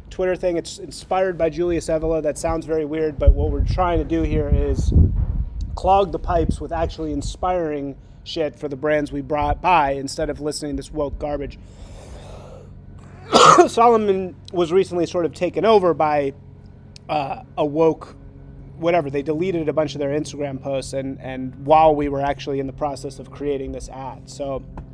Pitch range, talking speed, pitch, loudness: 135-165 Hz, 175 wpm, 150 Hz, -20 LUFS